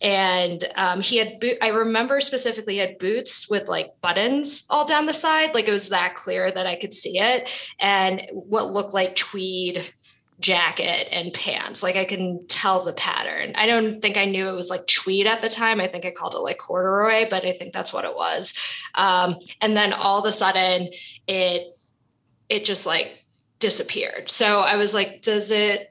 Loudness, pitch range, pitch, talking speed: -21 LUFS, 185-220 Hz, 195 Hz, 200 wpm